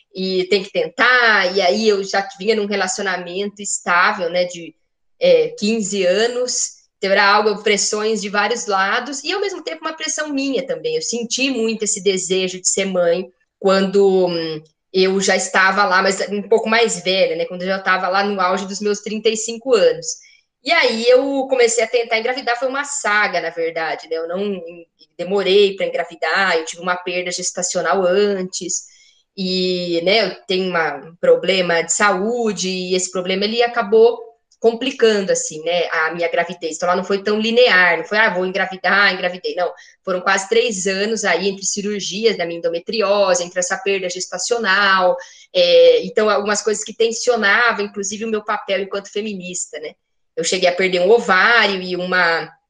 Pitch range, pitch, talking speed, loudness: 180-225 Hz, 200 Hz, 175 wpm, -17 LUFS